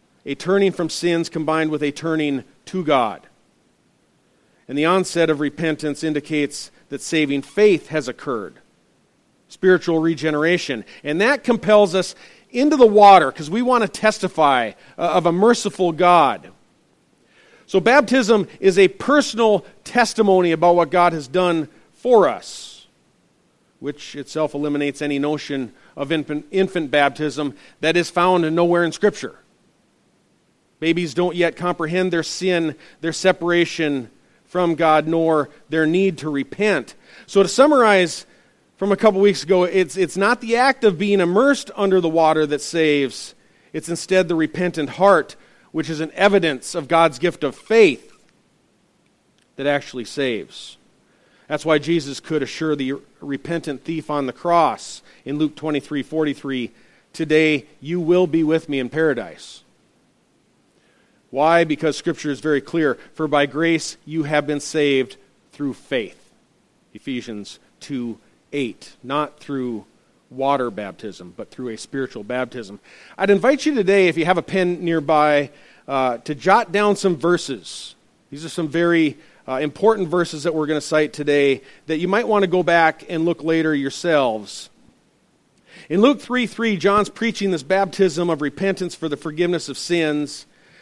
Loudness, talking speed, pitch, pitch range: -19 LUFS, 150 wpm, 165 Hz, 145-185 Hz